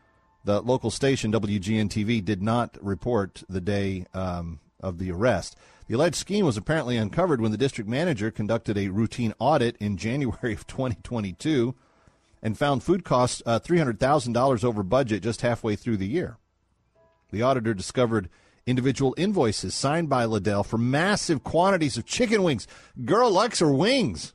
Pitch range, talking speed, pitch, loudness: 105-130 Hz, 155 wpm, 115 Hz, -25 LUFS